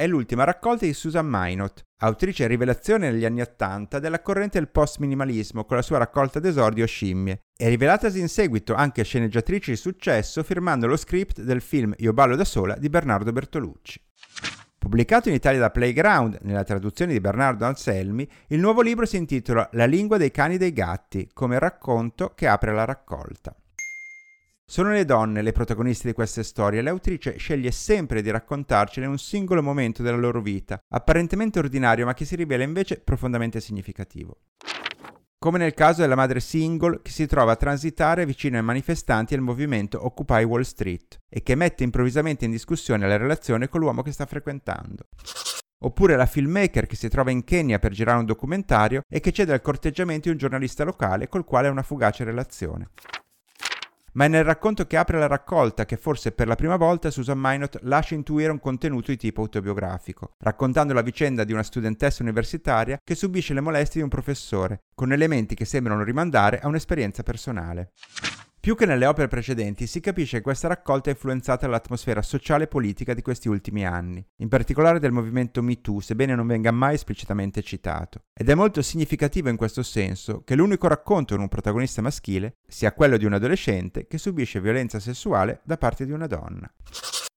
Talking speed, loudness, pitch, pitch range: 180 wpm, -23 LUFS, 130 Hz, 110-155 Hz